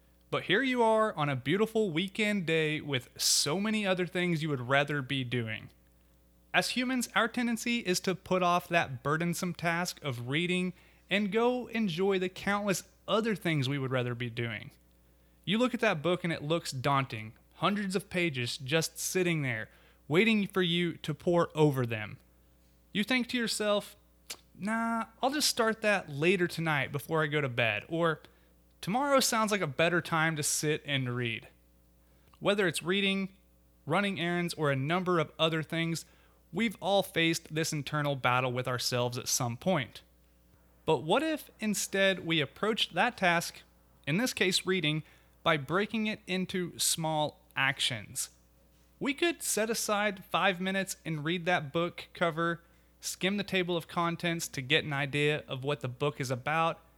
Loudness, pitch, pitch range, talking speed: -30 LUFS, 165 Hz, 135-195 Hz, 165 wpm